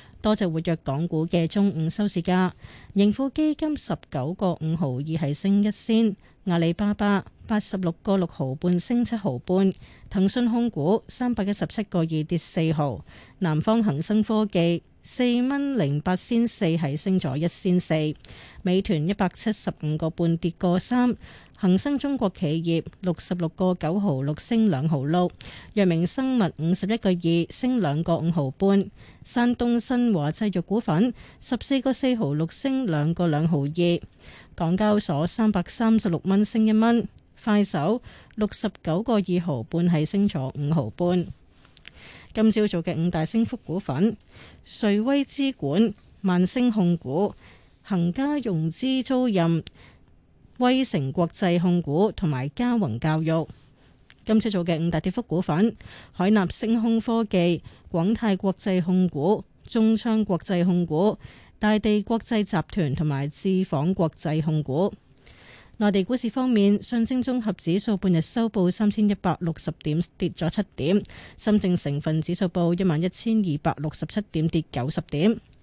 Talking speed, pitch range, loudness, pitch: 230 characters per minute, 165-215 Hz, -24 LUFS, 185 Hz